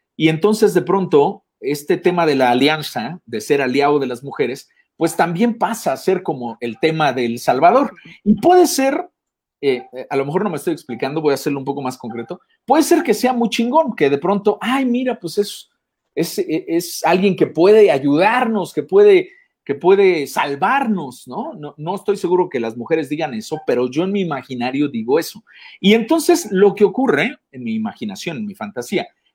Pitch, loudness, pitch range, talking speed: 195 Hz, -17 LUFS, 150-250 Hz, 195 wpm